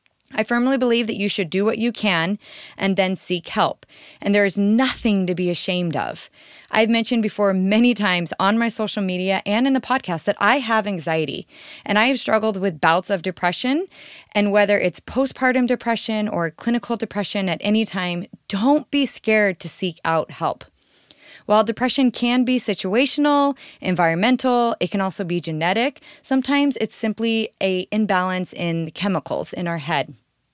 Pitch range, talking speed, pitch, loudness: 185-245 Hz, 170 wpm, 210 Hz, -20 LUFS